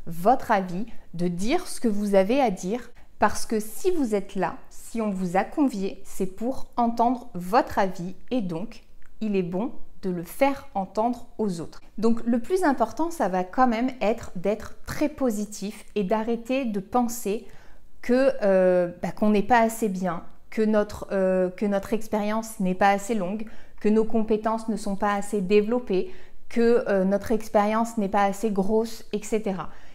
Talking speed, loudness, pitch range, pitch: 175 wpm, -25 LUFS, 195-235 Hz, 215 Hz